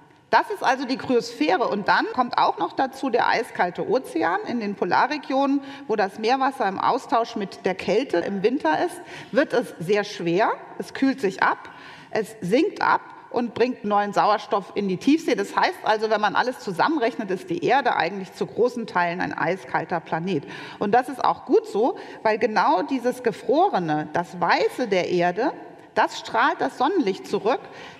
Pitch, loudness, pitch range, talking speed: 240 Hz, -23 LUFS, 205-290 Hz, 175 wpm